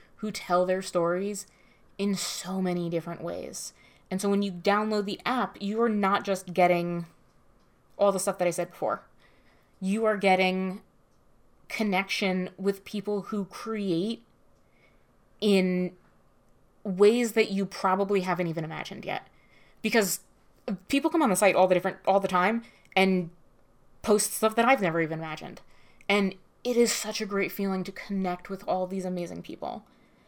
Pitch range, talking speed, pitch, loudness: 180-205 Hz, 155 wpm, 195 Hz, -28 LUFS